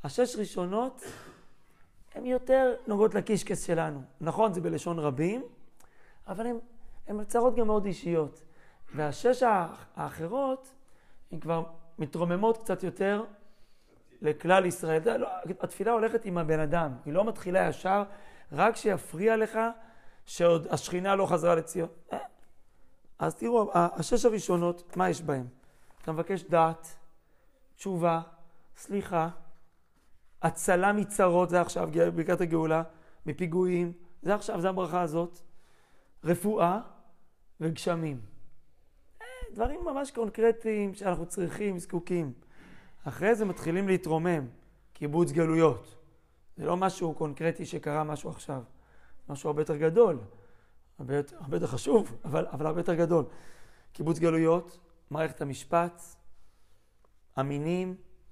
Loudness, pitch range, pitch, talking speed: -30 LUFS, 160-200 Hz, 175 Hz, 110 wpm